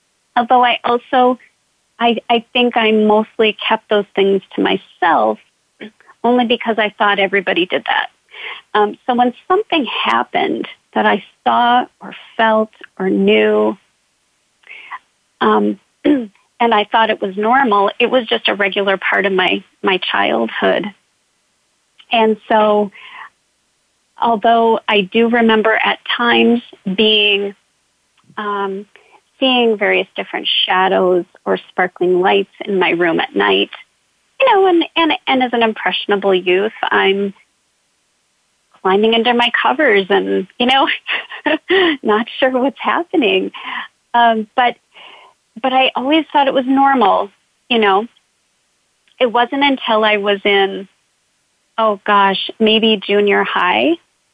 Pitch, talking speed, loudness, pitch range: 225 Hz, 125 wpm, -14 LUFS, 200-255 Hz